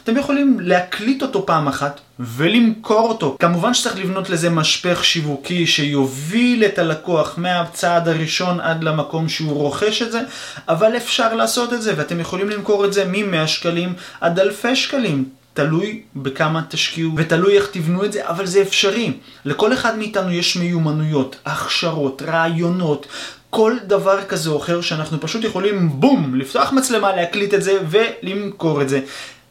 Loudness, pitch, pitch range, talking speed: -18 LUFS, 175 Hz, 155-210 Hz, 155 wpm